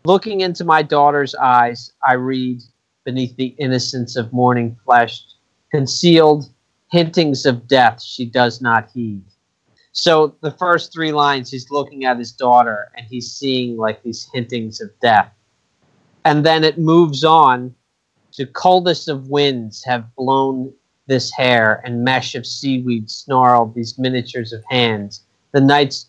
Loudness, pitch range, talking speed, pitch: -16 LUFS, 120-145 Hz, 145 wpm, 130 Hz